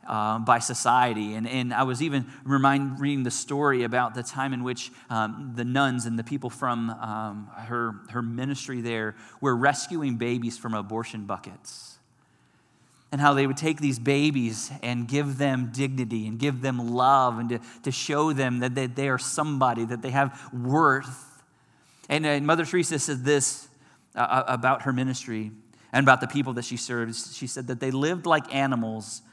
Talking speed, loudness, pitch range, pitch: 180 wpm, -26 LUFS, 120-140 Hz, 130 Hz